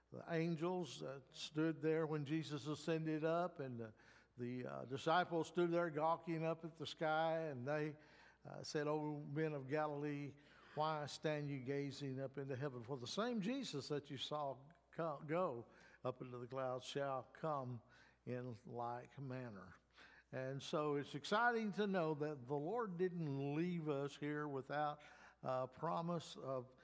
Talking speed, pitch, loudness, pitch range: 155 wpm, 150 Hz, -44 LUFS, 135-160 Hz